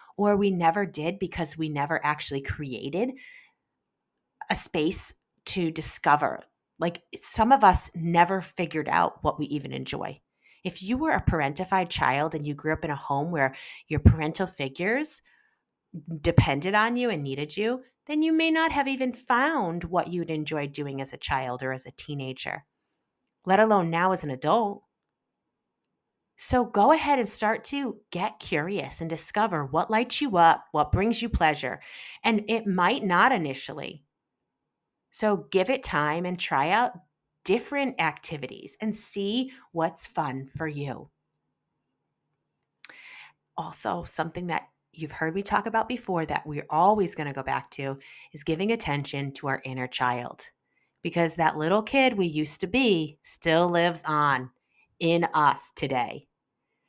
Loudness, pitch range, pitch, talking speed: -26 LUFS, 150-210 Hz, 170 Hz, 155 wpm